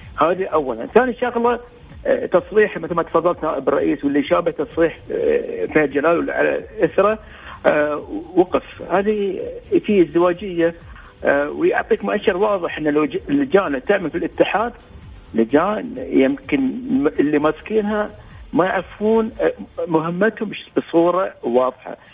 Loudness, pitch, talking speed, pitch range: -19 LUFS, 205 Hz, 105 wpm, 165-255 Hz